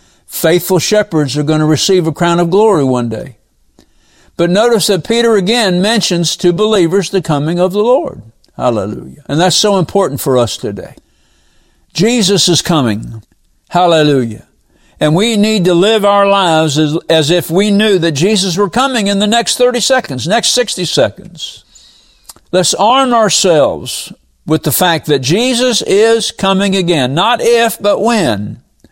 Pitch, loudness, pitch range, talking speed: 185 Hz, -11 LUFS, 155-210 Hz, 160 wpm